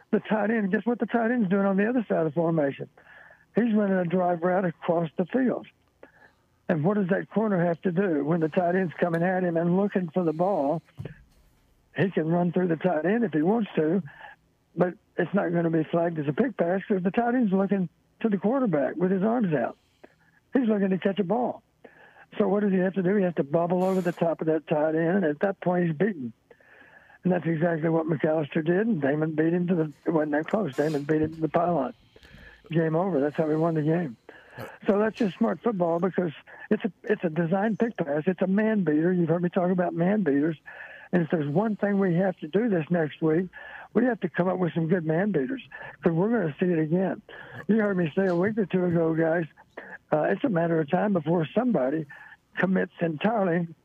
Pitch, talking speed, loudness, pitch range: 180 Hz, 235 wpm, -26 LUFS, 165-200 Hz